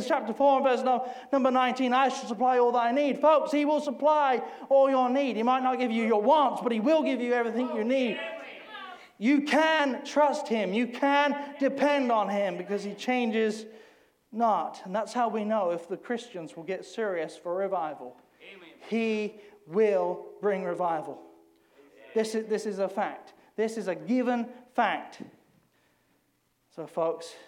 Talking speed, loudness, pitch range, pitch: 170 wpm, -27 LUFS, 210-270 Hz, 240 Hz